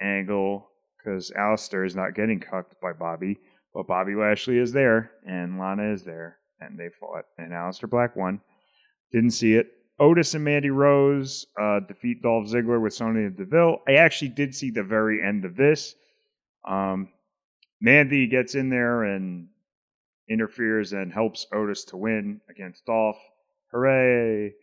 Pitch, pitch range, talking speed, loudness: 110 Hz, 100-130 Hz, 155 wpm, -23 LUFS